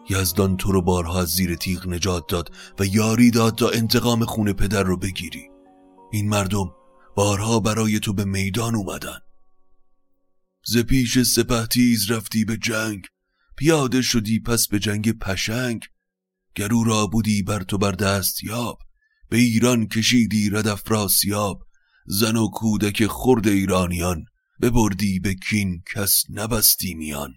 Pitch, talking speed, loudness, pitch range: 105 Hz, 135 wpm, -21 LUFS, 95-115 Hz